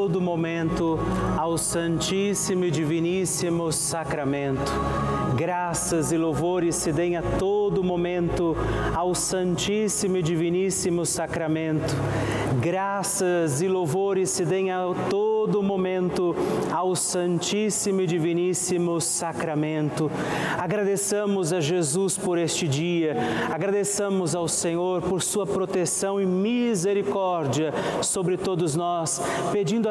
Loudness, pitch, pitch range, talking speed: -24 LUFS, 175 Hz, 165-190 Hz, 100 wpm